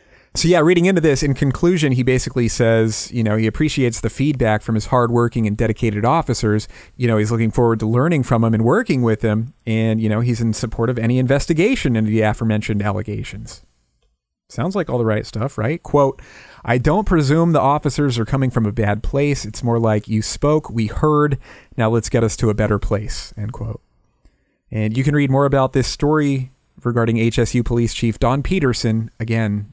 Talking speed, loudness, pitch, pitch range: 200 wpm, -18 LUFS, 115 Hz, 110-135 Hz